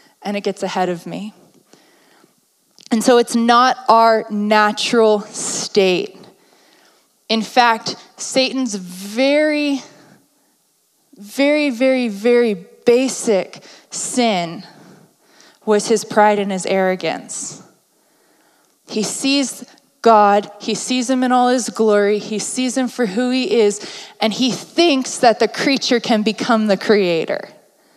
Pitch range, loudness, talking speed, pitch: 205-255 Hz, -16 LUFS, 120 wpm, 225 Hz